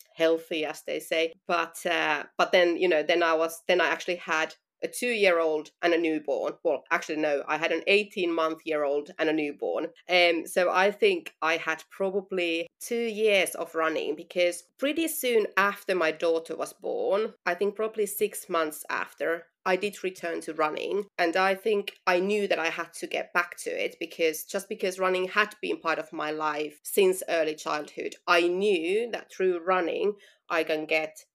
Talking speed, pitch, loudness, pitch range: 190 wpm, 175 Hz, -27 LUFS, 160-200 Hz